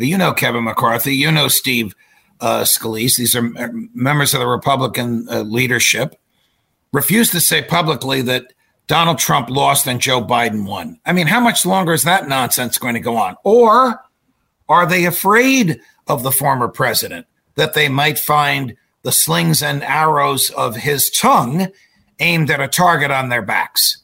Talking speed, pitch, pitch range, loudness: 165 wpm, 140 Hz, 125-170 Hz, -14 LUFS